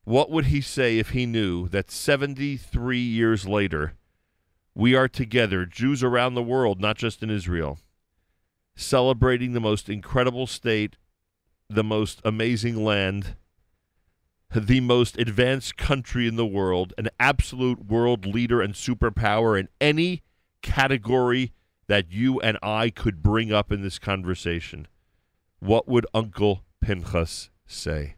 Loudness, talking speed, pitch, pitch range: -24 LUFS, 130 wpm, 110 Hz, 95-125 Hz